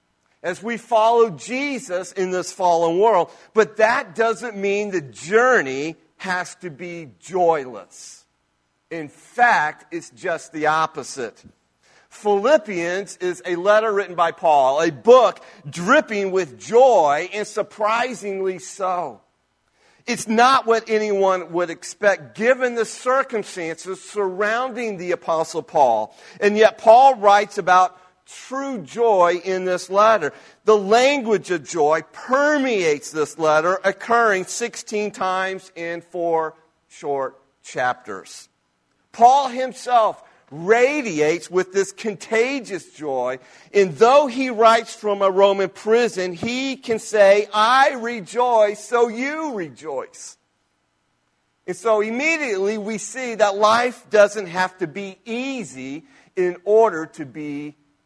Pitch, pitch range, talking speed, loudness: 200 Hz, 170-230 Hz, 120 wpm, -19 LUFS